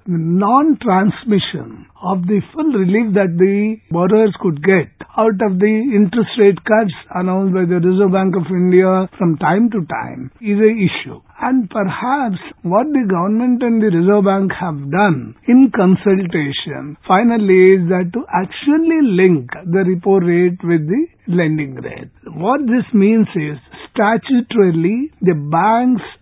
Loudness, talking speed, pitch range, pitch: -15 LUFS, 145 wpm, 180-220 Hz, 195 Hz